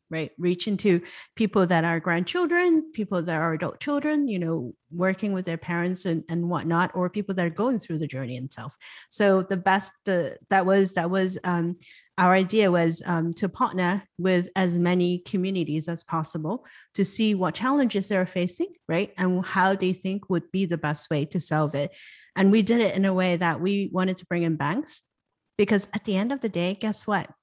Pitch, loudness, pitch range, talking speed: 185 Hz, -25 LUFS, 170-200 Hz, 205 wpm